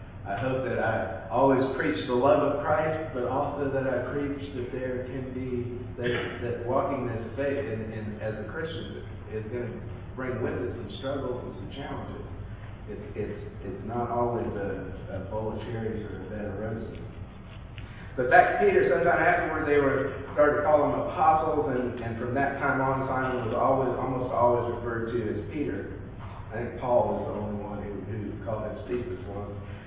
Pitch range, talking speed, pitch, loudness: 105-130 Hz, 185 wpm, 120 Hz, -28 LUFS